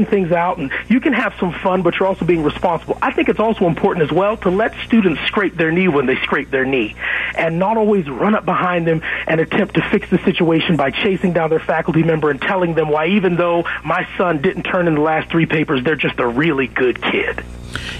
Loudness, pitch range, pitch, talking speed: -16 LUFS, 155-195 Hz, 175 Hz, 235 wpm